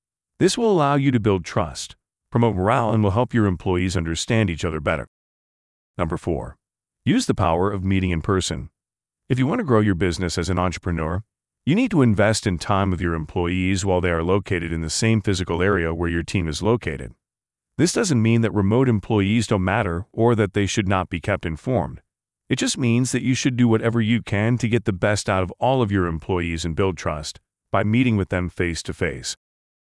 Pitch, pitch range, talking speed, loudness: 100 Hz, 90-115 Hz, 215 wpm, -21 LUFS